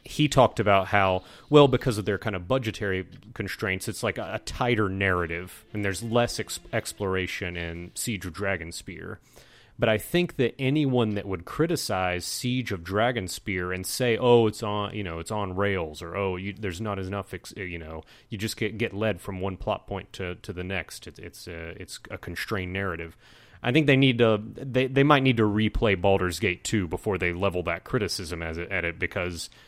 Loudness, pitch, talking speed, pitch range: -26 LUFS, 100 Hz, 200 wpm, 90-115 Hz